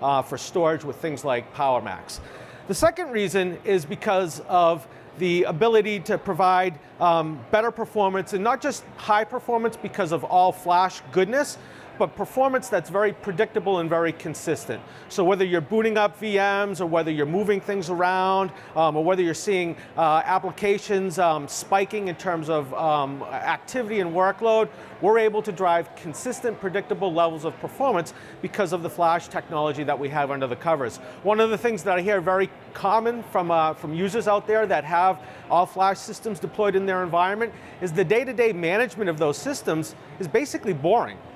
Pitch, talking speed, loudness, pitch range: 190 Hz, 175 wpm, -24 LUFS, 165-210 Hz